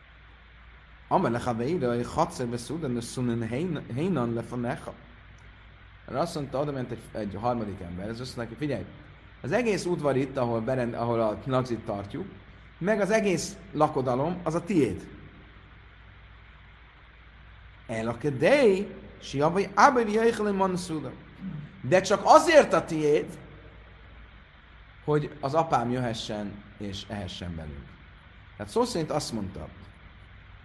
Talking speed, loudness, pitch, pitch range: 115 wpm, -27 LUFS, 115 Hz, 100-150 Hz